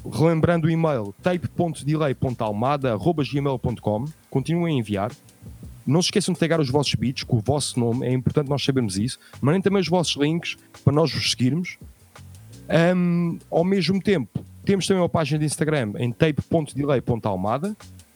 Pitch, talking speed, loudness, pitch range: 145 Hz, 150 wpm, -23 LUFS, 120-165 Hz